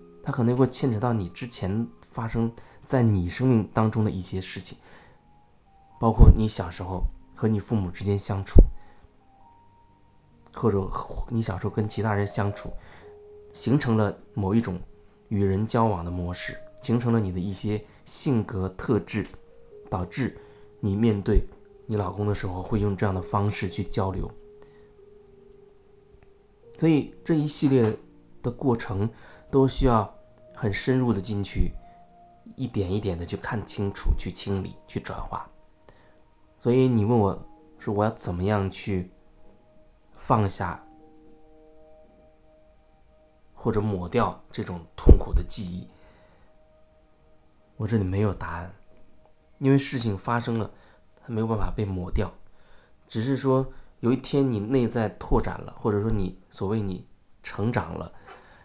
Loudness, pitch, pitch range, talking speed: -26 LUFS, 110 Hz, 95-130 Hz, 200 characters per minute